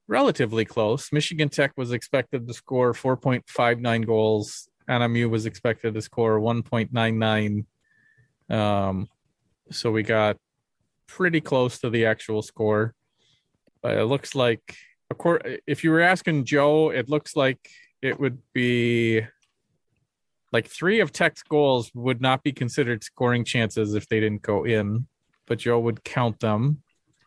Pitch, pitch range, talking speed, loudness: 120 Hz, 110-140 Hz, 140 wpm, -24 LUFS